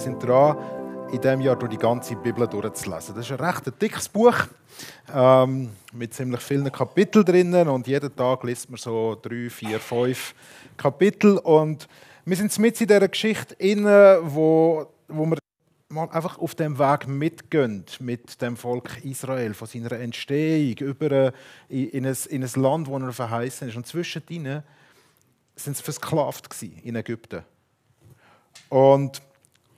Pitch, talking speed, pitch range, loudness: 135 Hz, 145 wpm, 120-155 Hz, -22 LUFS